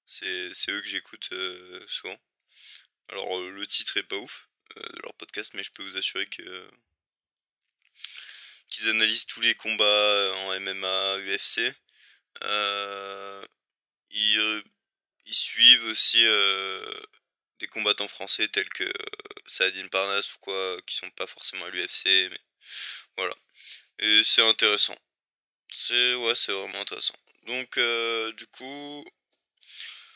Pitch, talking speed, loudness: 115 Hz, 135 wpm, -24 LUFS